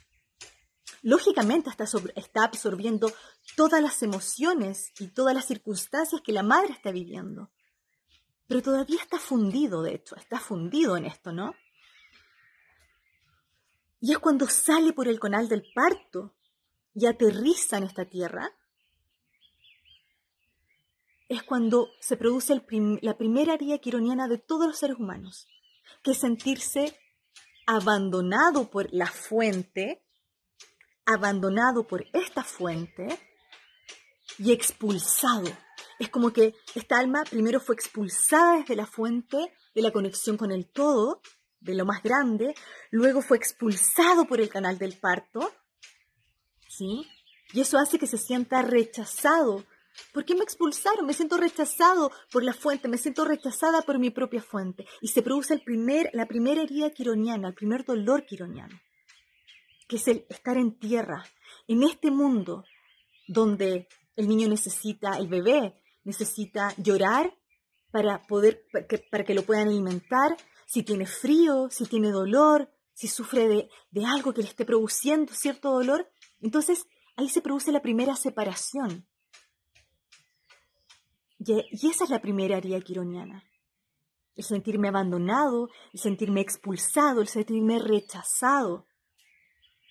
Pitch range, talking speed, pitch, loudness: 205-280 Hz, 135 wpm, 230 Hz, -26 LUFS